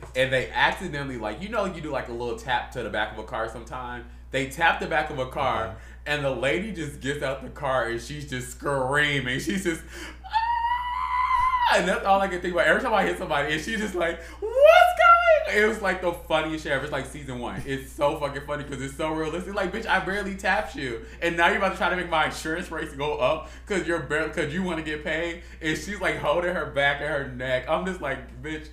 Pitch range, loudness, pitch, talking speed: 140-195 Hz, -25 LUFS, 160 Hz, 250 wpm